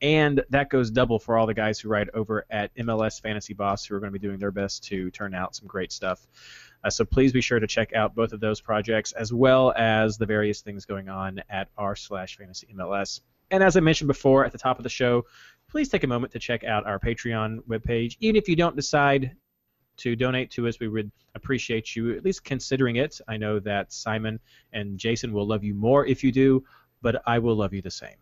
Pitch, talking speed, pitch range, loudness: 115 Hz, 240 wpm, 105-130 Hz, -25 LUFS